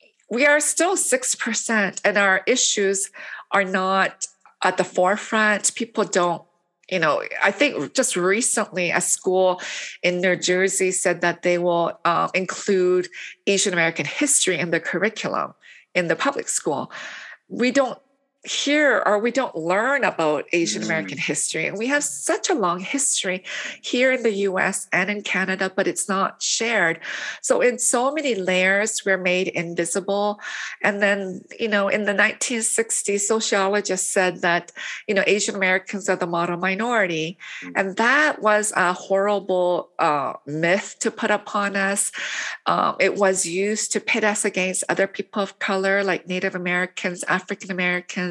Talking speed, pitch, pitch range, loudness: 155 wpm, 195 Hz, 185-225 Hz, -21 LUFS